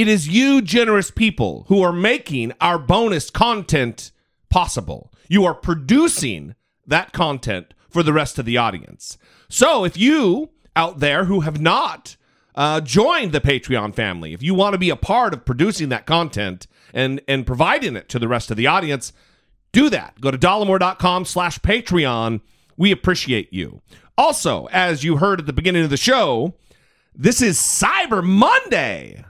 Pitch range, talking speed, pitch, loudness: 130-195 Hz, 165 wpm, 165 Hz, -18 LUFS